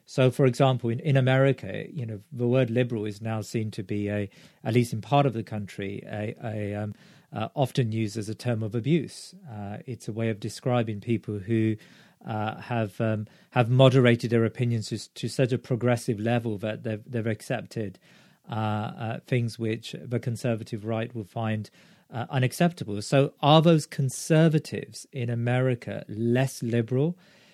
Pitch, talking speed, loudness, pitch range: 120 Hz, 170 wpm, -27 LUFS, 110-130 Hz